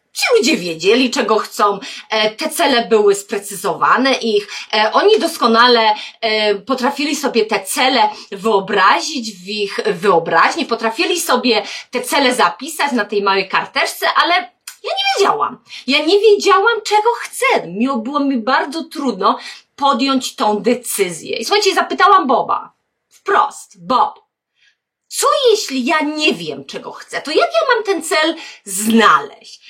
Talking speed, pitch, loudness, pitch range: 130 wpm, 255 Hz, -15 LUFS, 215-330 Hz